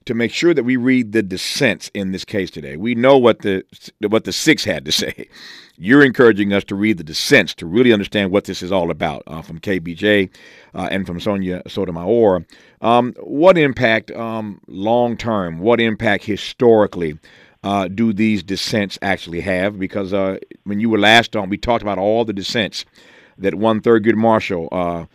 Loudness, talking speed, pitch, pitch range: -17 LUFS, 185 wpm, 105 Hz, 95-115 Hz